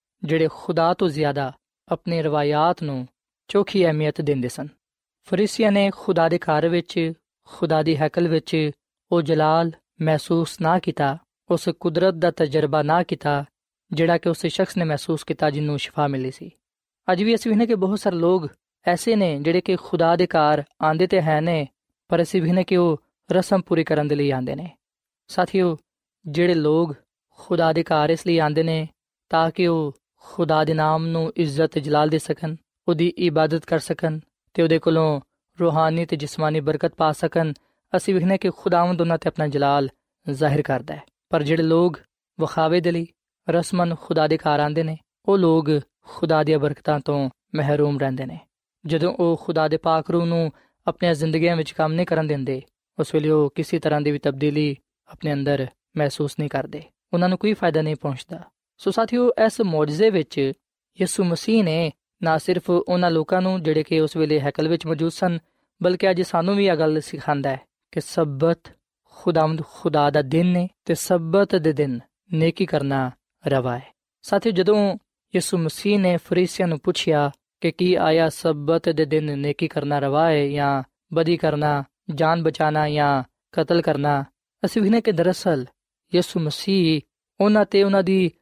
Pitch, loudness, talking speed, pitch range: 165 Hz, -21 LUFS, 170 wpm, 150-175 Hz